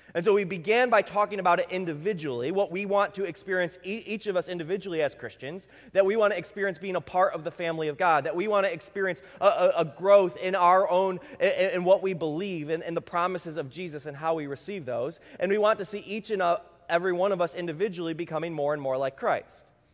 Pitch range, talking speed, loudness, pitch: 170-195 Hz, 240 wpm, -27 LUFS, 185 Hz